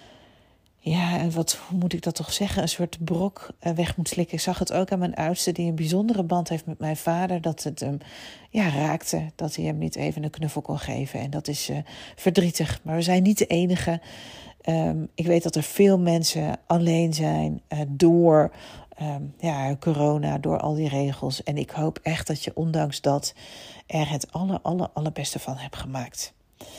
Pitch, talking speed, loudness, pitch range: 160 Hz, 200 wpm, -25 LUFS, 145-170 Hz